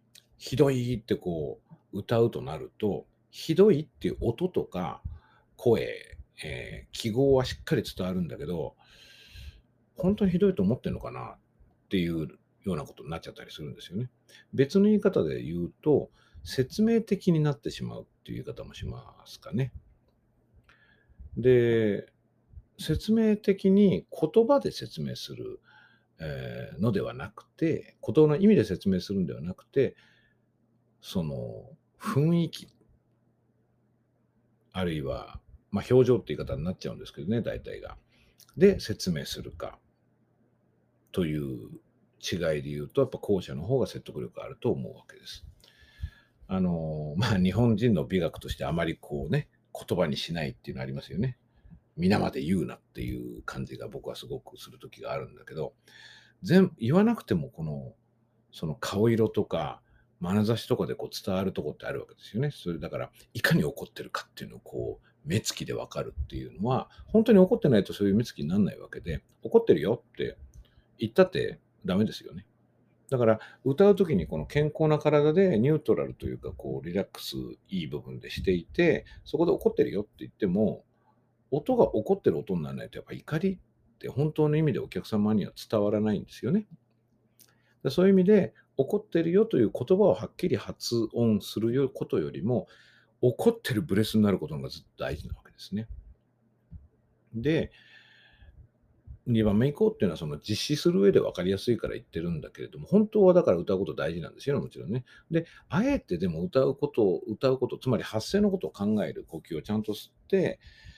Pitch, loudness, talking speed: 120 Hz, -28 LUFS, 345 characters per minute